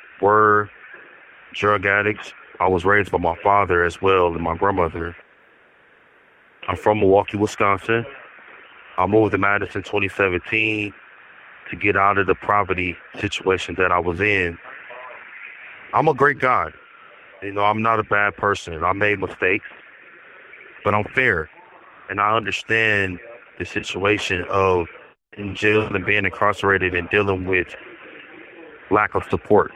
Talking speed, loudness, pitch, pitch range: 135 wpm, -20 LUFS, 100 Hz, 90-105 Hz